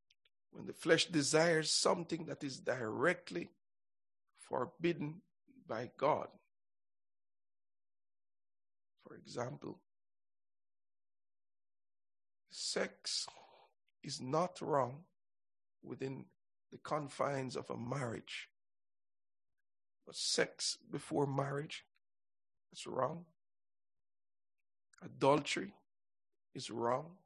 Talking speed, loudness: 70 wpm, -38 LUFS